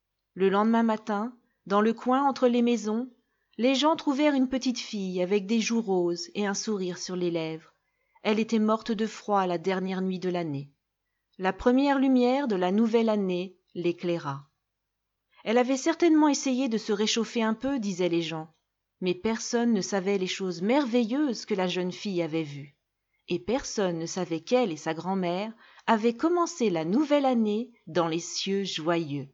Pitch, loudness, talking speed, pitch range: 205 Hz, -27 LUFS, 175 wpm, 175-240 Hz